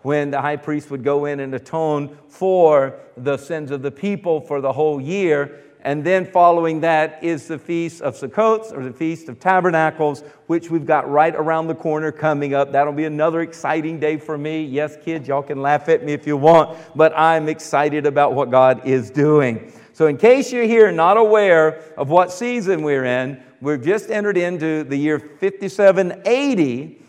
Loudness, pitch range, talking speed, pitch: -18 LUFS, 145-165 Hz, 190 wpm, 155 Hz